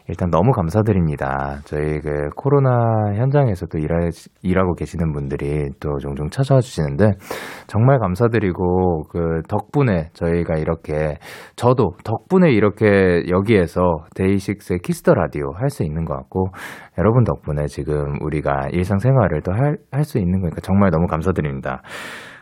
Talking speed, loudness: 325 characters per minute, -19 LUFS